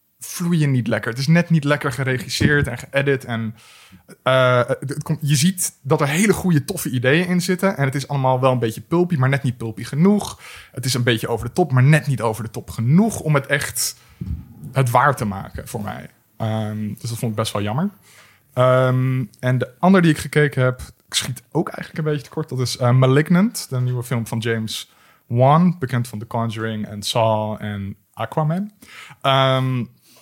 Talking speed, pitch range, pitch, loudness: 205 wpm, 115-150 Hz, 130 Hz, -19 LUFS